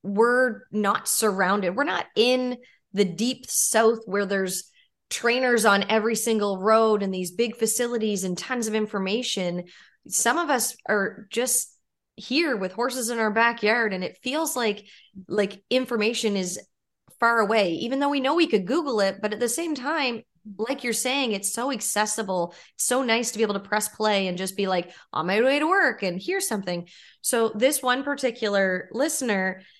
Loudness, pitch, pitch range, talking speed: -24 LUFS, 220 Hz, 200-250 Hz, 180 wpm